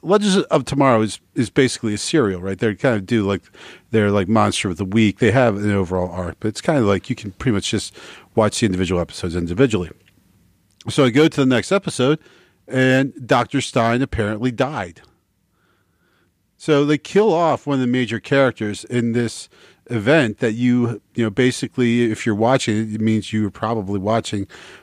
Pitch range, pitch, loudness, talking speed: 100-130 Hz, 115 Hz, -19 LUFS, 190 wpm